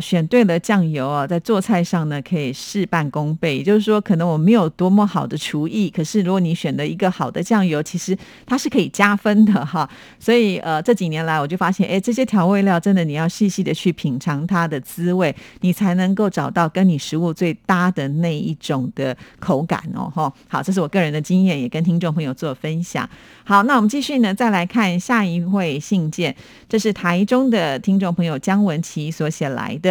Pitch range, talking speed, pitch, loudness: 160-200 Hz, 315 characters per minute, 180 Hz, -19 LUFS